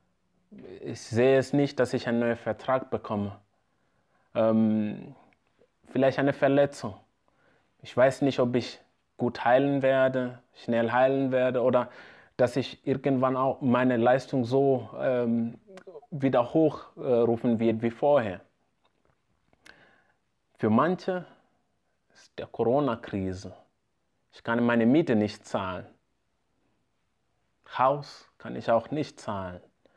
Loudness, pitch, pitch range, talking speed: -26 LUFS, 125 Hz, 115-135 Hz, 115 wpm